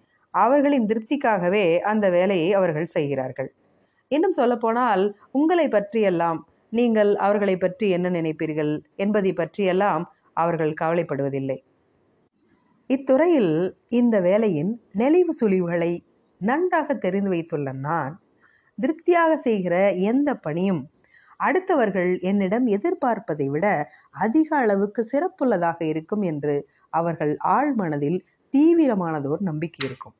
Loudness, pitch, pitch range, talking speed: -22 LUFS, 195 Hz, 165-245 Hz, 95 wpm